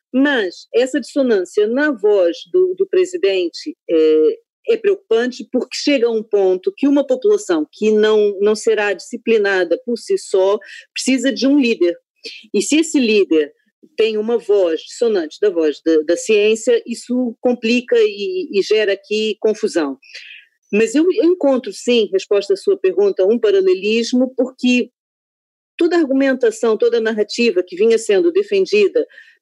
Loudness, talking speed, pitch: -16 LUFS, 145 wpm, 260 Hz